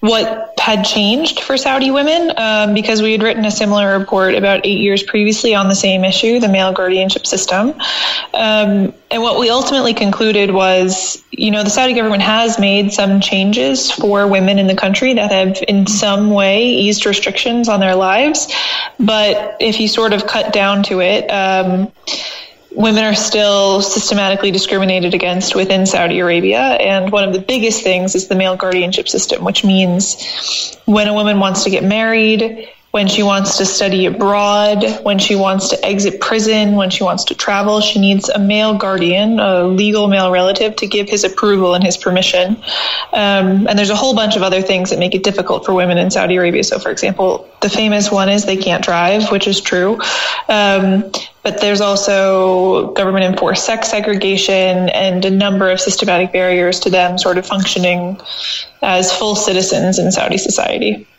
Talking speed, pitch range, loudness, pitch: 180 wpm, 190-215 Hz, -13 LUFS, 200 Hz